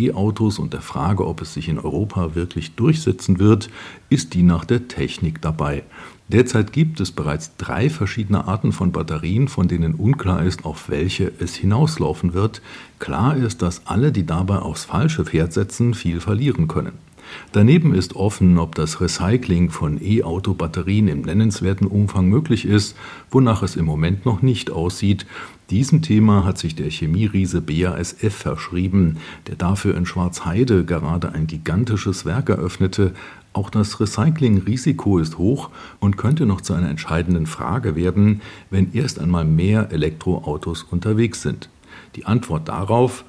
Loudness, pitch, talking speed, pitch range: -20 LUFS, 95 Hz, 150 wpm, 85-110 Hz